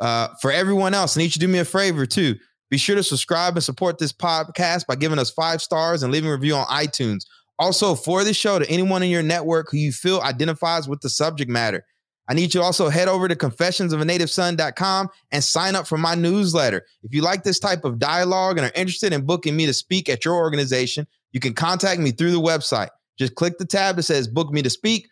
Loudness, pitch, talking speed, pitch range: -20 LUFS, 165 Hz, 235 wpm, 145-180 Hz